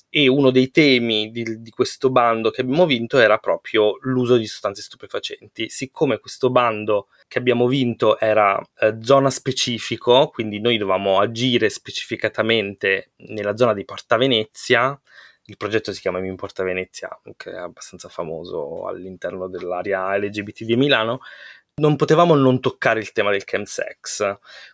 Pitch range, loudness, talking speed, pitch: 105-130 Hz, -19 LUFS, 150 wpm, 115 Hz